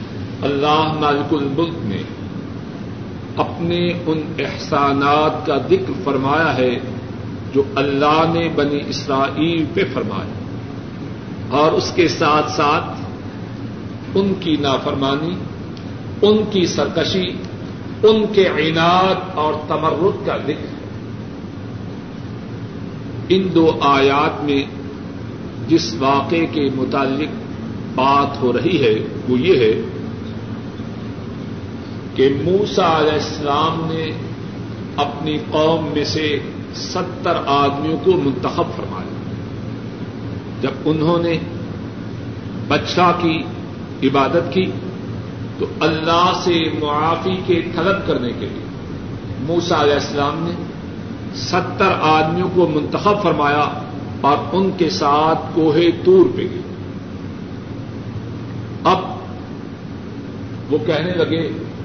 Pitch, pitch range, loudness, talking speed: 140 Hz, 110-160 Hz, -18 LUFS, 100 wpm